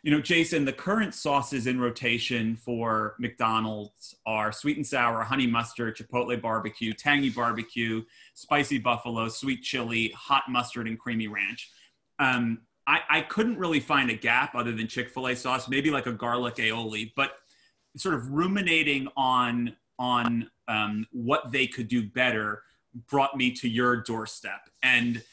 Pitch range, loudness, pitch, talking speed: 115-135 Hz, -27 LUFS, 120 Hz, 150 wpm